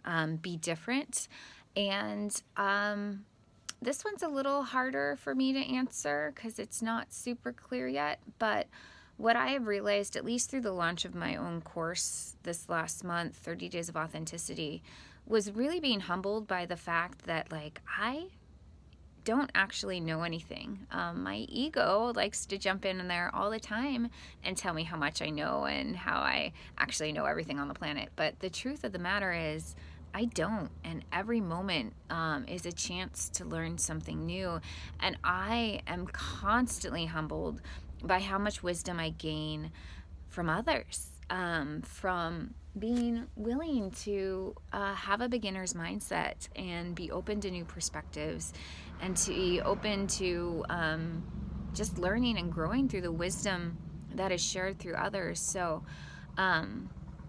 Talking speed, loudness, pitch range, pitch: 160 wpm, -34 LUFS, 160-210 Hz, 180 Hz